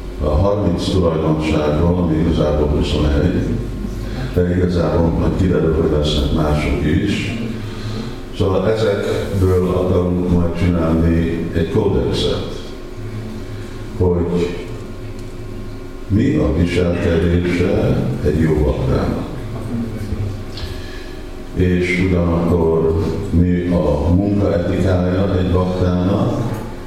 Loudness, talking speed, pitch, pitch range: -17 LUFS, 80 wpm, 90 Hz, 85-105 Hz